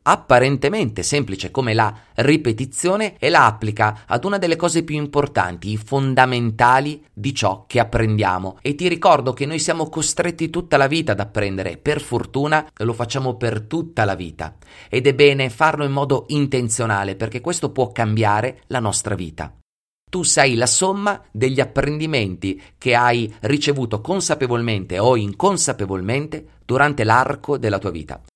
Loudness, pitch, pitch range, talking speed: -19 LUFS, 125 Hz, 110-145 Hz, 150 wpm